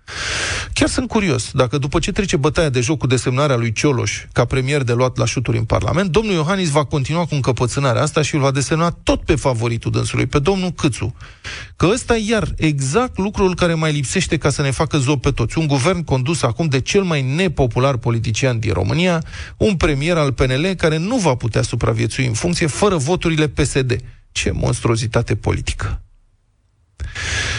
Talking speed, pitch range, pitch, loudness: 185 wpm, 120-165 Hz, 140 Hz, -18 LUFS